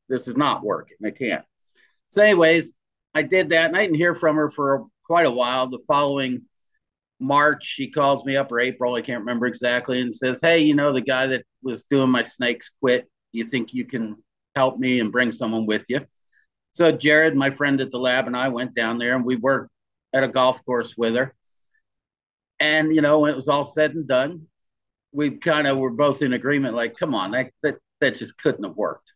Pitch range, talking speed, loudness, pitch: 125-150 Hz, 220 wpm, -21 LUFS, 130 Hz